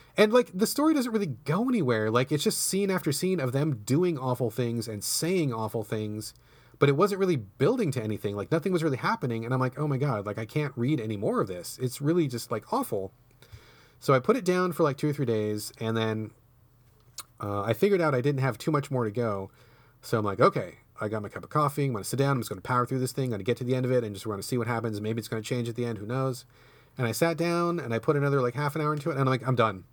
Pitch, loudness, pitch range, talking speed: 130 Hz, -28 LUFS, 115-150 Hz, 295 wpm